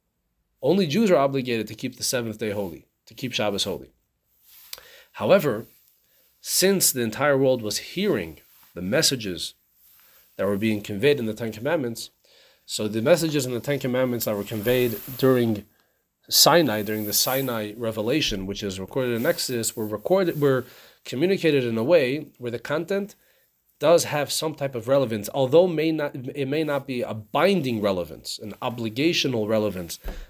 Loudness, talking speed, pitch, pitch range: -23 LUFS, 160 wpm, 125 Hz, 110-145 Hz